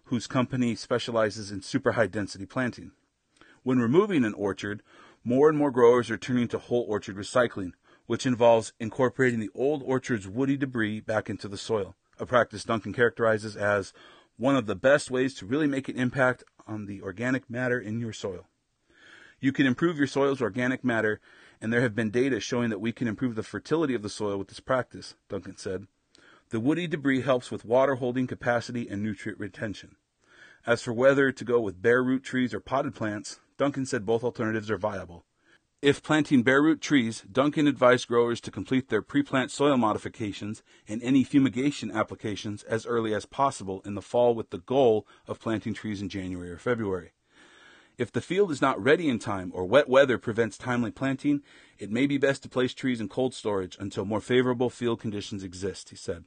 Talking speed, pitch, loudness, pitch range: 190 wpm, 120 Hz, -27 LUFS, 105-130 Hz